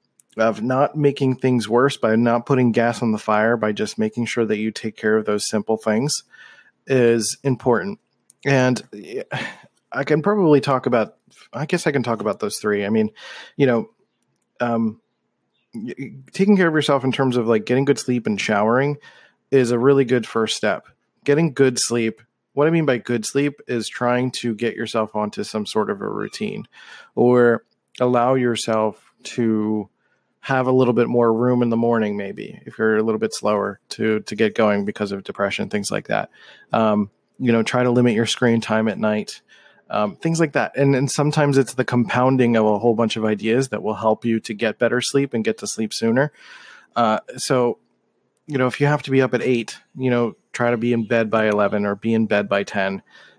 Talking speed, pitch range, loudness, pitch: 205 wpm, 110-135 Hz, -20 LUFS, 120 Hz